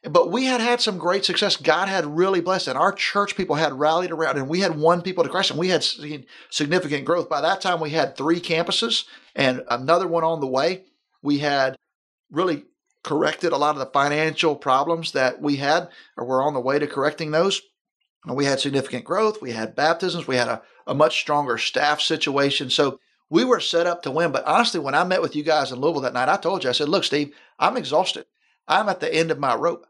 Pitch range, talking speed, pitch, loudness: 140-180 Hz, 235 wpm, 160 Hz, -22 LUFS